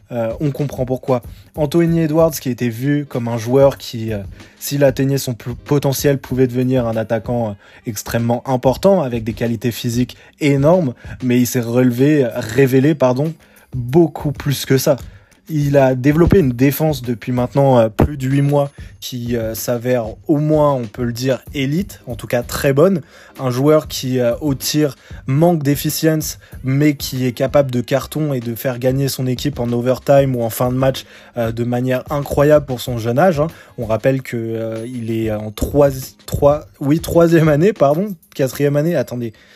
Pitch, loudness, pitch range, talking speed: 130 Hz, -17 LUFS, 120-145 Hz, 175 wpm